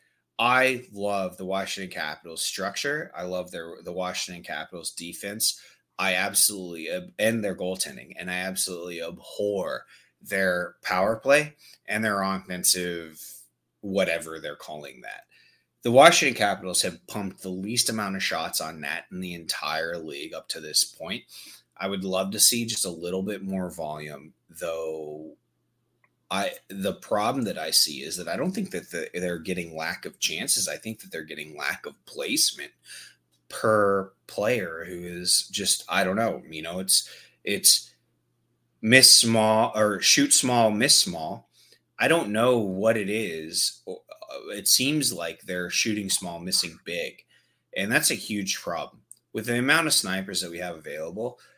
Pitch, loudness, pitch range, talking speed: 95 Hz, -24 LUFS, 85-110 Hz, 160 wpm